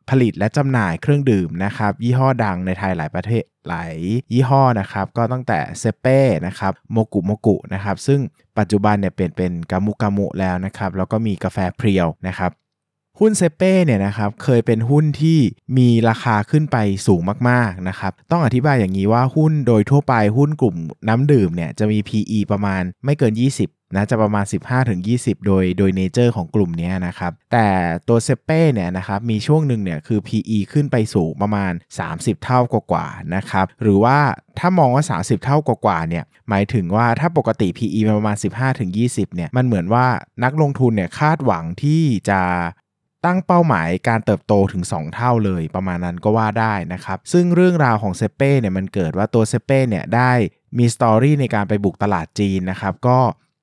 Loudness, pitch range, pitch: -18 LUFS, 95-125 Hz, 110 Hz